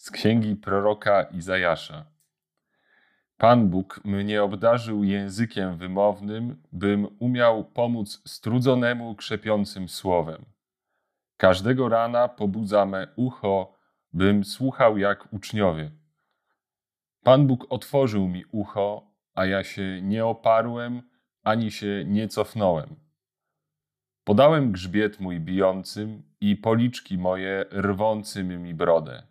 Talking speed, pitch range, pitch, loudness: 100 wpm, 95-115 Hz, 105 Hz, -24 LUFS